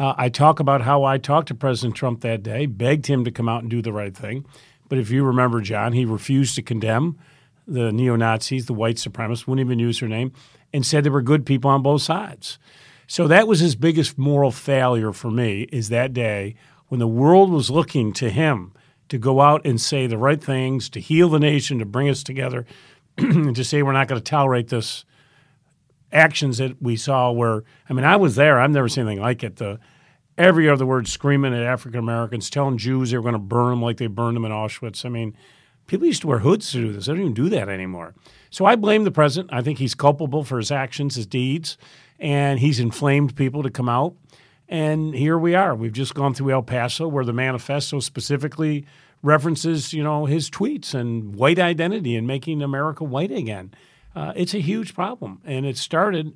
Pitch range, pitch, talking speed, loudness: 120-150 Hz, 135 Hz, 220 wpm, -20 LUFS